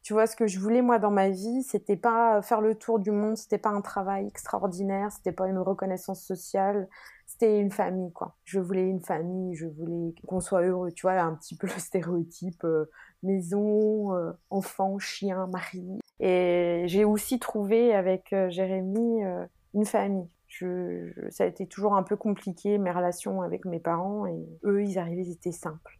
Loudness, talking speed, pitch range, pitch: -28 LUFS, 190 wpm, 180-210 Hz, 190 Hz